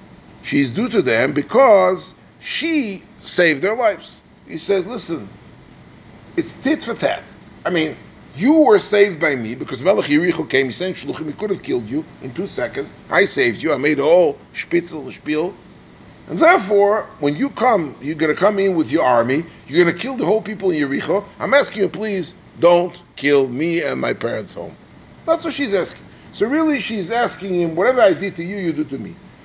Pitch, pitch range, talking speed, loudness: 195 Hz, 170-265 Hz, 195 wpm, -18 LUFS